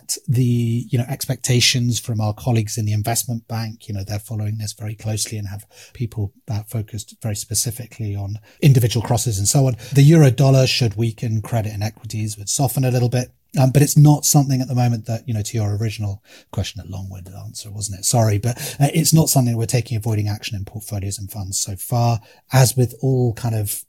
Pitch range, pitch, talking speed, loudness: 105-125 Hz, 115 Hz, 215 wpm, -19 LUFS